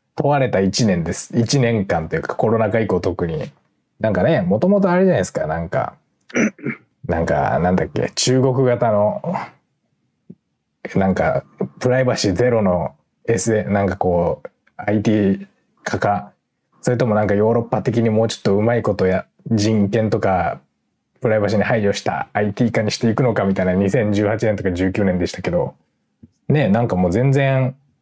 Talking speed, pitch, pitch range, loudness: 320 characters per minute, 110 Hz, 100-120 Hz, -18 LUFS